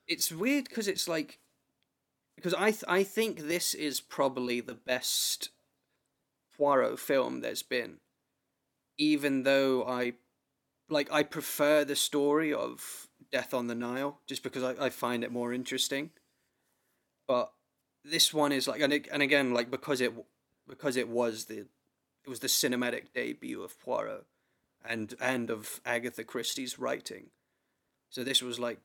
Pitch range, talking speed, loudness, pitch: 125-150 Hz, 150 wpm, -31 LUFS, 135 Hz